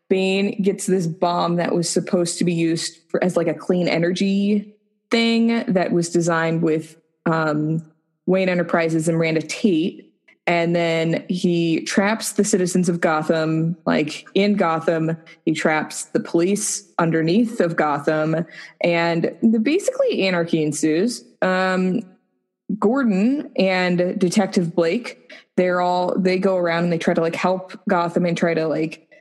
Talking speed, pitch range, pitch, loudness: 145 wpm, 165-190 Hz, 175 Hz, -20 LUFS